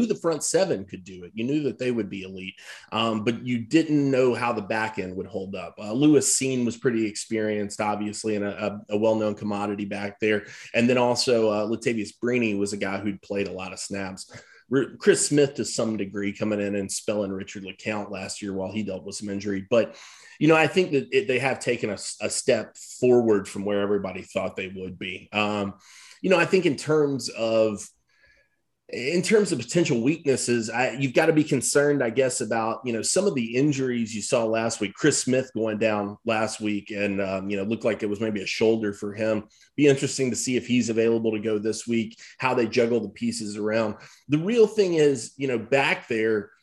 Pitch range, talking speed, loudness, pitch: 105-130 Hz, 220 wpm, -25 LUFS, 110 Hz